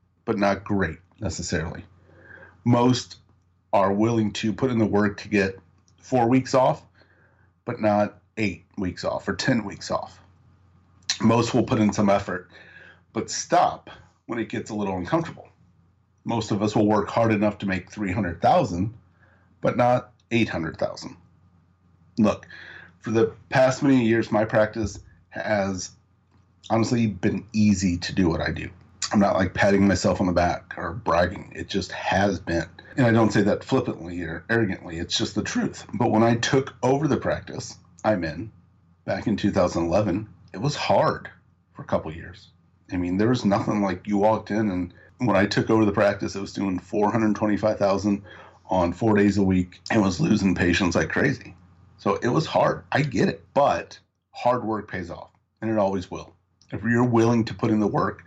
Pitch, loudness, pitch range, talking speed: 100 Hz, -24 LUFS, 90-110 Hz, 175 wpm